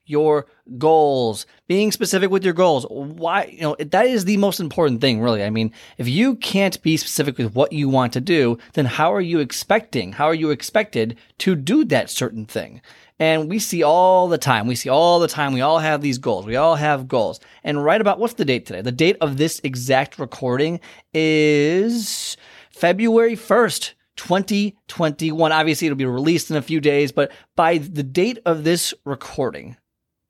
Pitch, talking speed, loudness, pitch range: 155 Hz, 190 wpm, -19 LUFS, 135-180 Hz